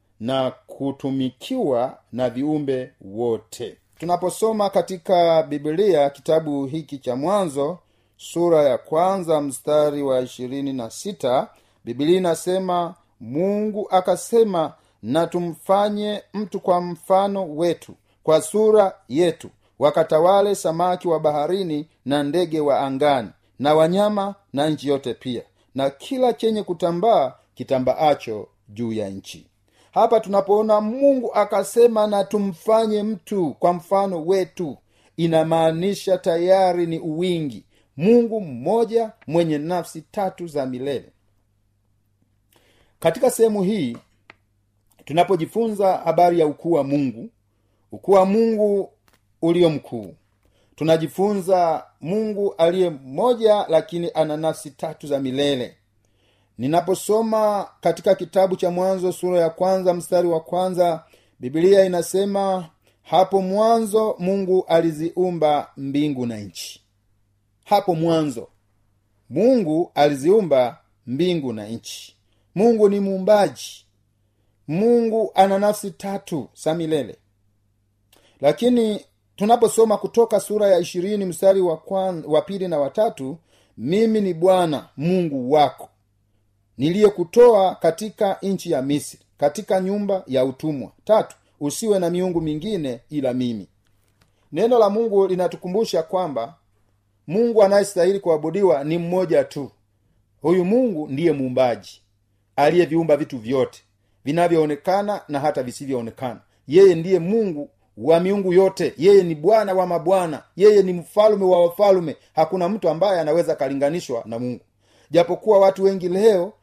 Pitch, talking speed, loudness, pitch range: 170 Hz, 115 wpm, -20 LUFS, 130-195 Hz